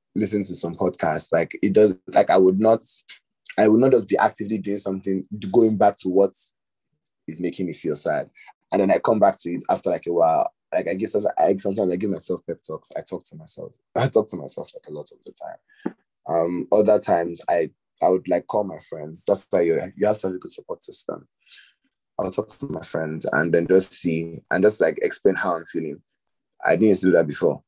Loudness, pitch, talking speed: -22 LUFS, 105 Hz, 235 wpm